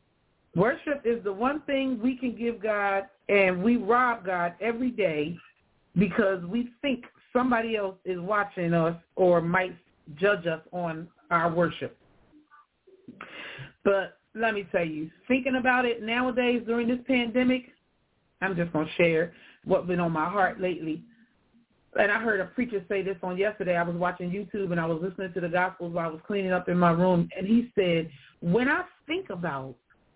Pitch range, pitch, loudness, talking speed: 175-235 Hz, 195 Hz, -27 LUFS, 175 wpm